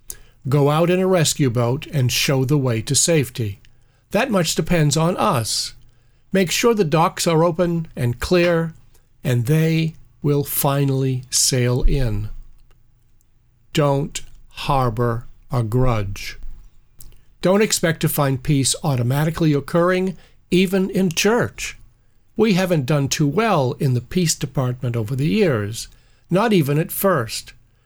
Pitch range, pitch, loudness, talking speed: 120-165 Hz, 135 Hz, -19 LUFS, 130 wpm